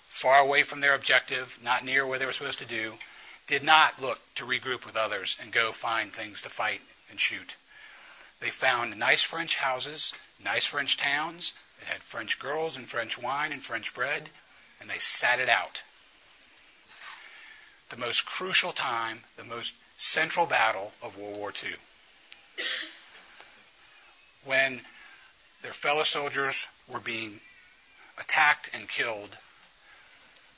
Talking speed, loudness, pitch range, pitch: 140 wpm, -27 LUFS, 120-140 Hz, 130 Hz